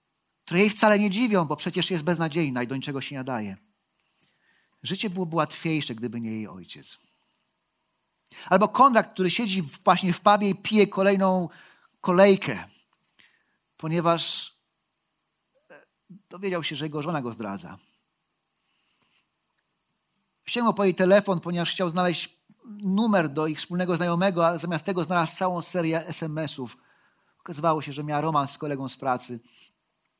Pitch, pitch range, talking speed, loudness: 175 Hz, 150-190 Hz, 135 wpm, -24 LUFS